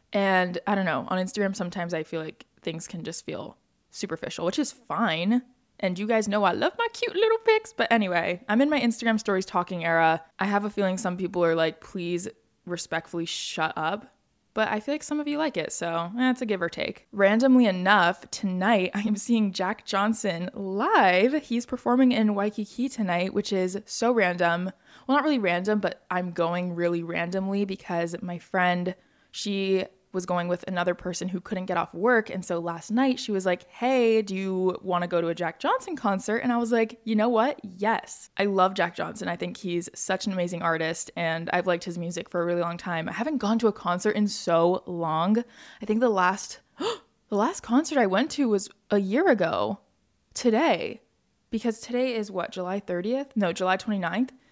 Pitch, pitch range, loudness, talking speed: 195 Hz, 175-230 Hz, -26 LUFS, 205 wpm